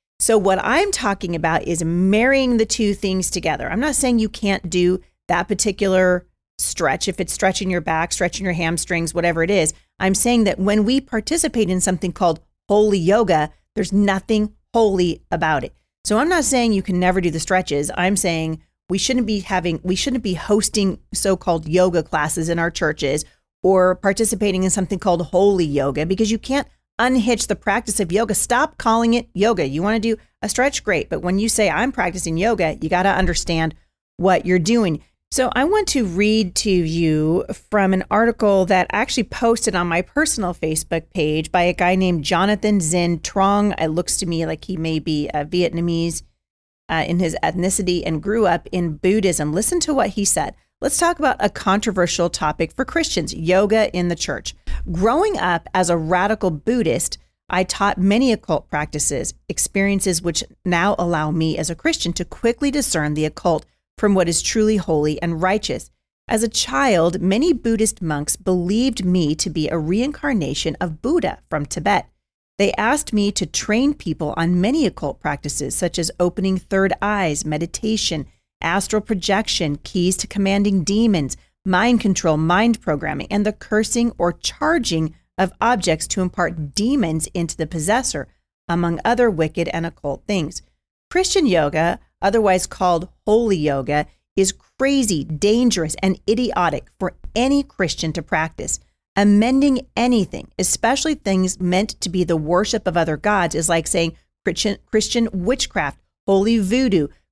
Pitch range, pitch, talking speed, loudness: 170-220 Hz, 190 Hz, 170 wpm, -19 LUFS